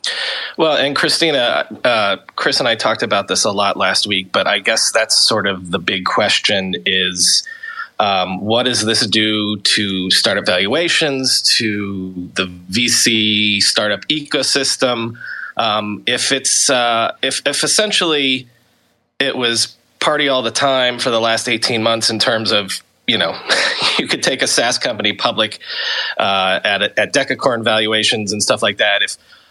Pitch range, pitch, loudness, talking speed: 105-130 Hz, 115 Hz, -15 LUFS, 160 wpm